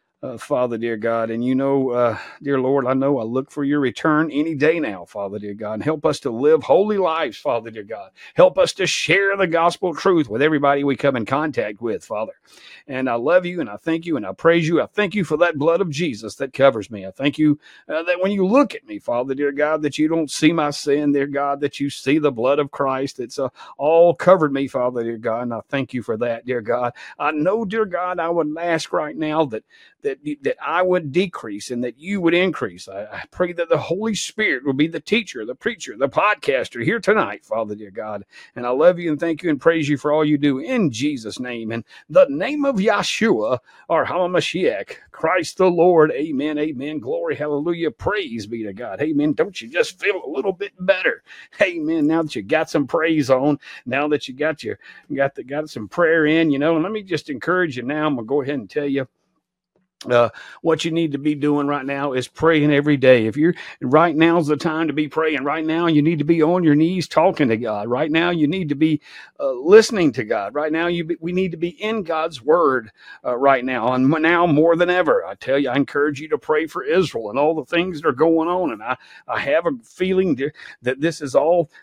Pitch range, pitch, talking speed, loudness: 140-175 Hz, 155 Hz, 240 wpm, -20 LUFS